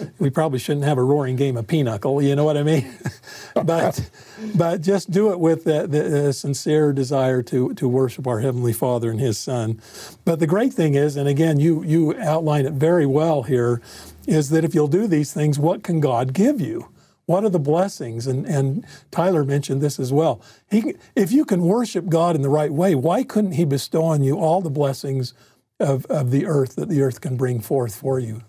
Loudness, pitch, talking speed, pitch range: -20 LUFS, 150 Hz, 210 wpm, 135-165 Hz